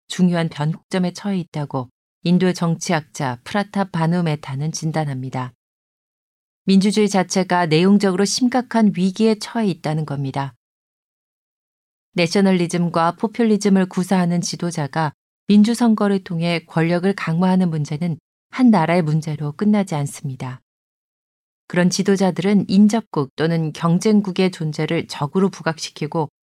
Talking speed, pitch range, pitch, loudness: 305 characters per minute, 155-195 Hz, 175 Hz, -19 LUFS